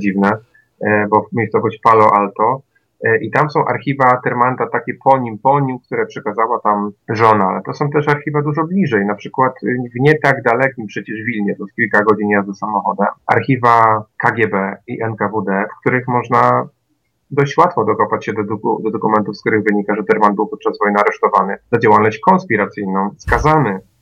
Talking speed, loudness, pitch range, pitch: 170 wpm, -15 LUFS, 105-130 Hz, 115 Hz